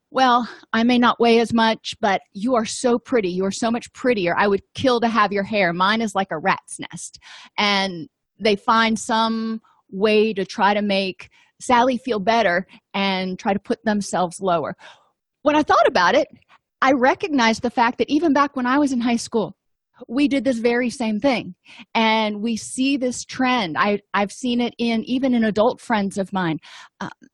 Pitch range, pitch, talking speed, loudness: 200-245 Hz, 225 Hz, 195 wpm, -20 LUFS